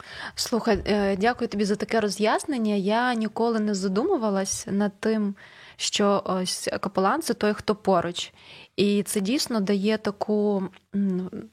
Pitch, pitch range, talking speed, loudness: 210 Hz, 200-220 Hz, 120 wpm, -25 LUFS